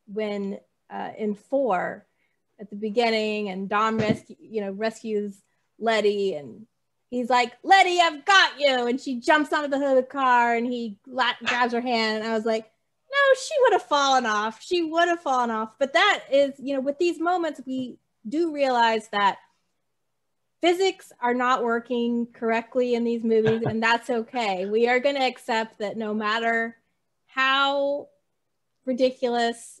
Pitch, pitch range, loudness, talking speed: 240 Hz, 220-275 Hz, -23 LUFS, 170 wpm